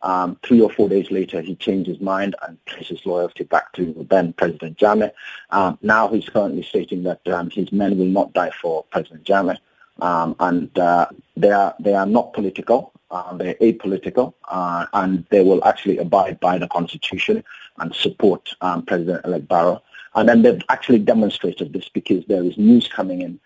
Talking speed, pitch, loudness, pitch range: 185 wpm, 95 Hz, -19 LUFS, 90-100 Hz